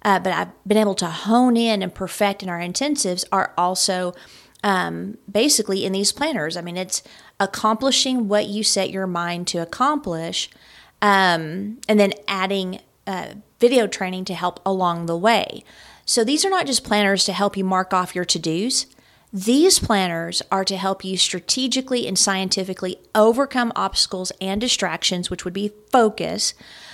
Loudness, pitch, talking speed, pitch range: -20 LUFS, 195 Hz, 165 wpm, 185-220 Hz